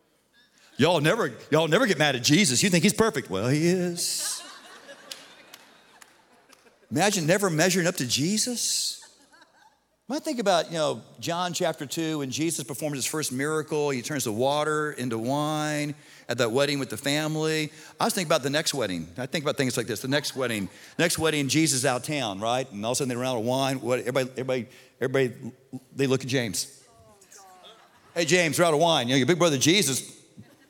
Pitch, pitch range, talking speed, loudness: 150 Hz, 130-165 Hz, 195 wpm, -25 LUFS